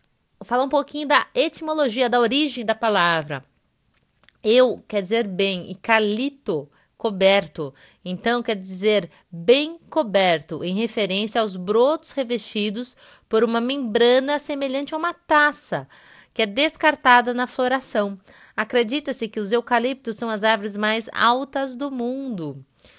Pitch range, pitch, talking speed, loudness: 210-270 Hz, 230 Hz, 130 wpm, -21 LUFS